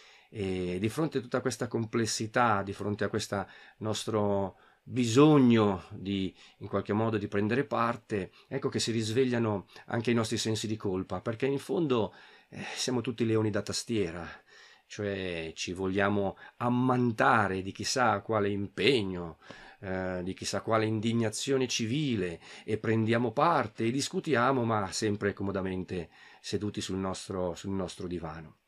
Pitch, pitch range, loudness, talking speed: 110 Hz, 95-120 Hz, -30 LUFS, 140 wpm